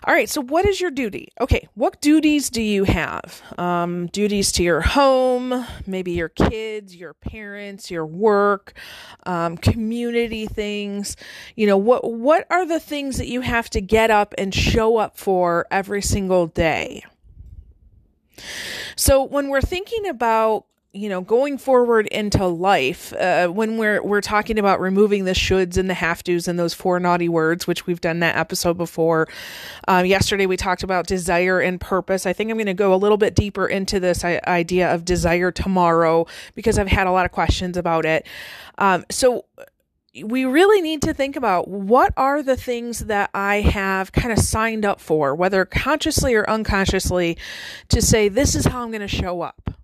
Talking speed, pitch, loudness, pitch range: 180 wpm, 200 Hz, -19 LUFS, 180-230 Hz